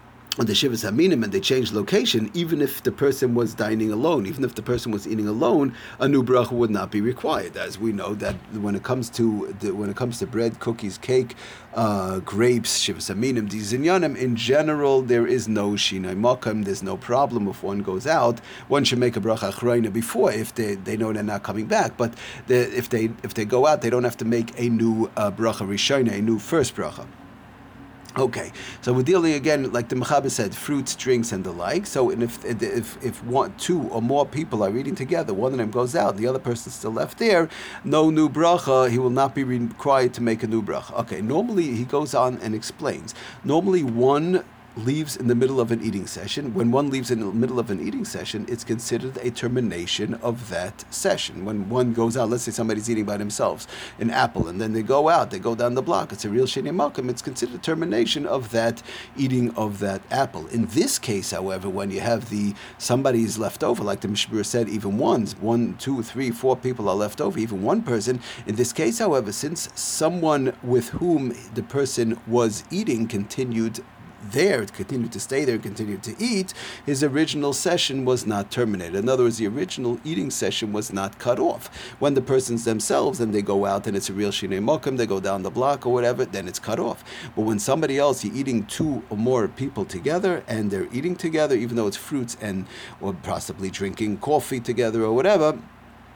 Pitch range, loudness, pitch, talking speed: 110-130 Hz, -23 LUFS, 120 Hz, 215 wpm